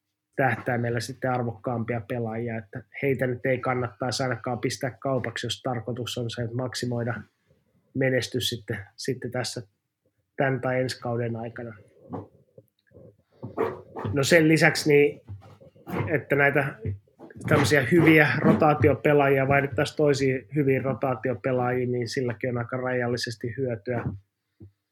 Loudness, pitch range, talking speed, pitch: -25 LUFS, 120-135 Hz, 115 wpm, 125 Hz